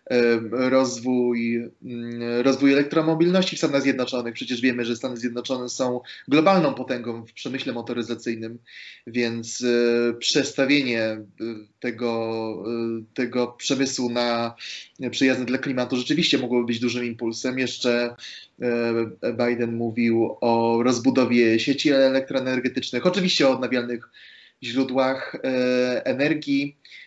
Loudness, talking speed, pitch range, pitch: -23 LUFS, 95 wpm, 120-130 Hz, 125 Hz